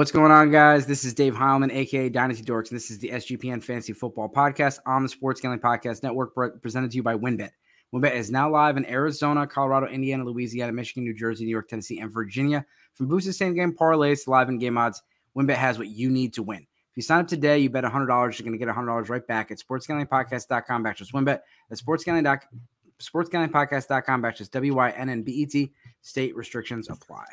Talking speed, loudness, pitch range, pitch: 195 wpm, -24 LUFS, 120-140 Hz, 130 Hz